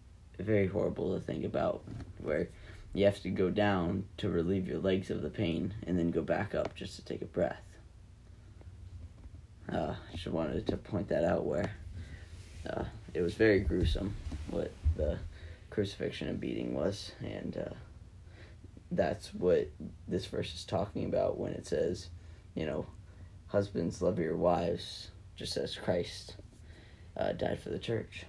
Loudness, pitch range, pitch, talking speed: -35 LUFS, 85-100 Hz, 90 Hz, 155 wpm